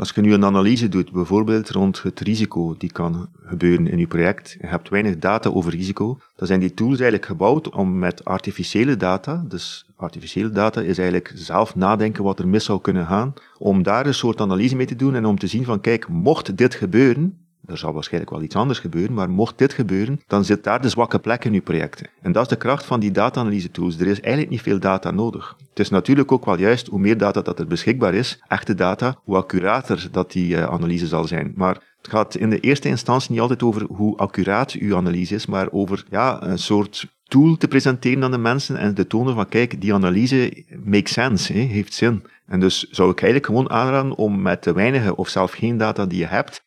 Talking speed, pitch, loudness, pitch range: 230 wpm, 105 Hz, -20 LUFS, 95-125 Hz